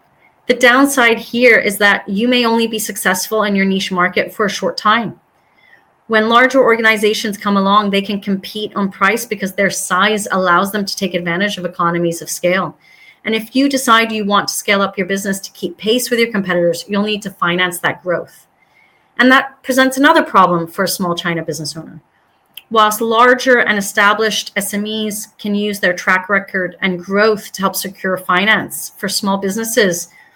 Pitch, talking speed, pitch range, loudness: 205 Hz, 185 wpm, 190-220 Hz, -14 LUFS